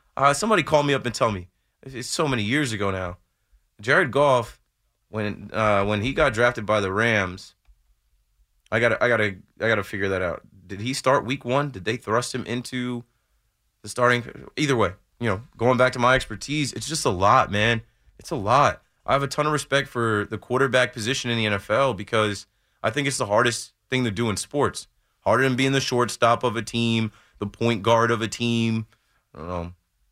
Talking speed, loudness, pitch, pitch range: 210 wpm, -23 LUFS, 115 Hz, 105-130 Hz